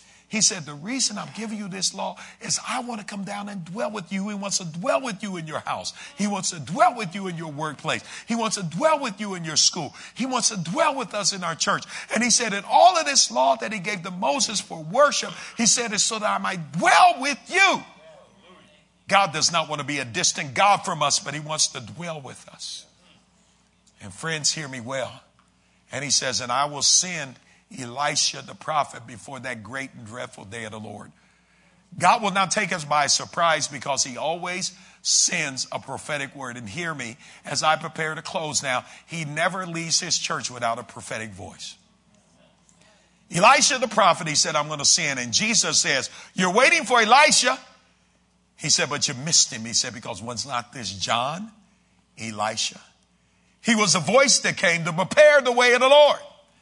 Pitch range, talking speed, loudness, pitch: 145-210 Hz, 210 wpm, -21 LUFS, 175 Hz